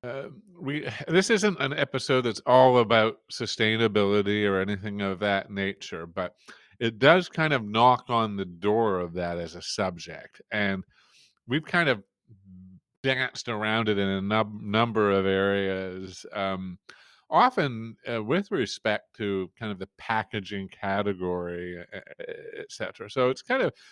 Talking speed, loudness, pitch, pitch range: 150 wpm, -26 LUFS, 105 Hz, 95-125 Hz